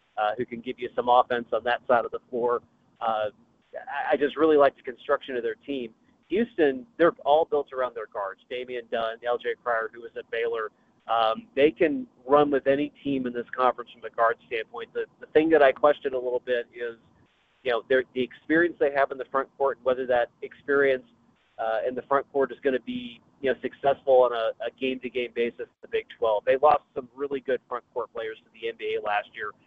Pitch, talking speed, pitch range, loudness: 135 Hz, 225 wpm, 125-170 Hz, -26 LUFS